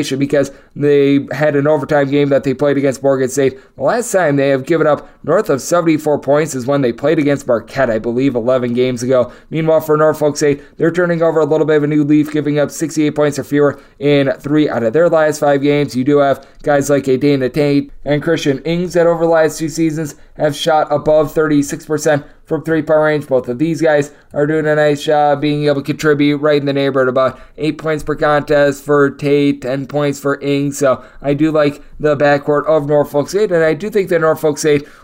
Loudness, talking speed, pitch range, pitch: -14 LUFS, 225 wpm, 140-155 Hz, 145 Hz